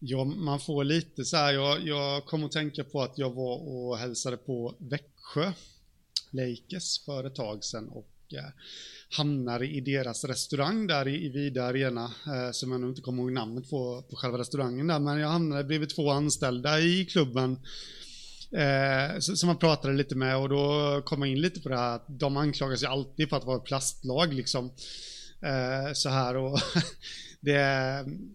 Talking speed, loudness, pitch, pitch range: 180 wpm, -30 LUFS, 140 Hz, 130-150 Hz